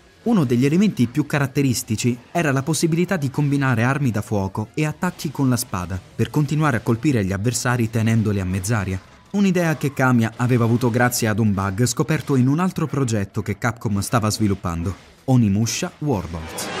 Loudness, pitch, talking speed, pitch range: -21 LUFS, 125 Hz, 170 wpm, 110-150 Hz